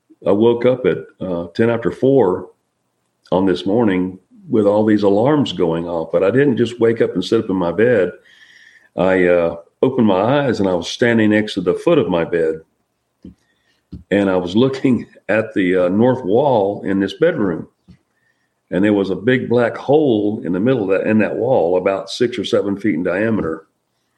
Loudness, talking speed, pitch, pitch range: -16 LUFS, 195 wpm, 100 Hz, 90-115 Hz